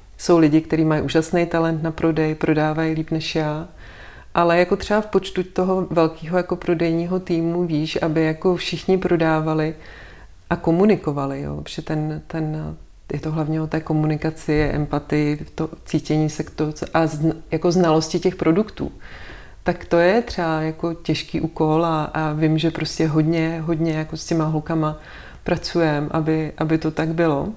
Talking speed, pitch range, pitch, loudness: 165 wpm, 155-170 Hz, 160 Hz, -21 LUFS